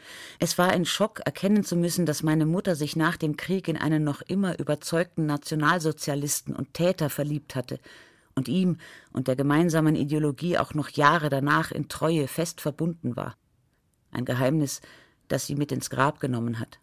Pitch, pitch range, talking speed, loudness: 155 Hz, 145-170 Hz, 170 wpm, -26 LUFS